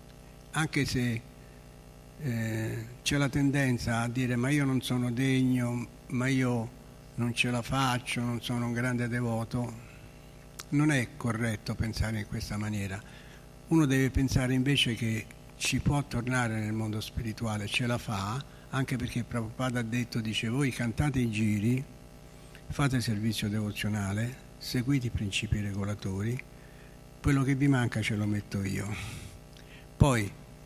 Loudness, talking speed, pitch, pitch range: -30 LUFS, 140 wpm, 120 Hz, 110-130 Hz